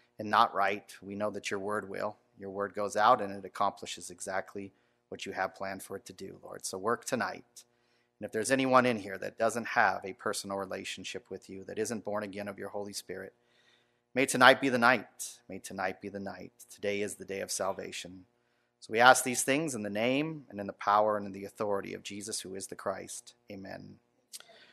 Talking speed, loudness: 220 wpm, -31 LUFS